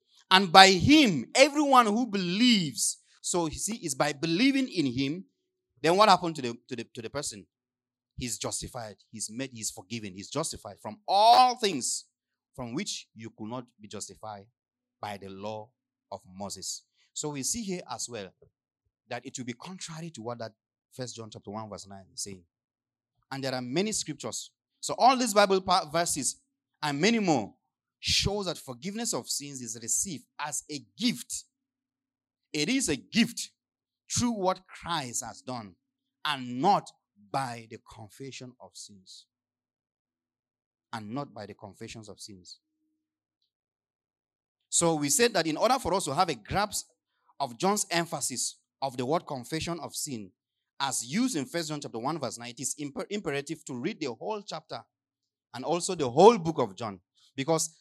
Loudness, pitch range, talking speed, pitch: -27 LUFS, 115-175 Hz, 165 wpm, 135 Hz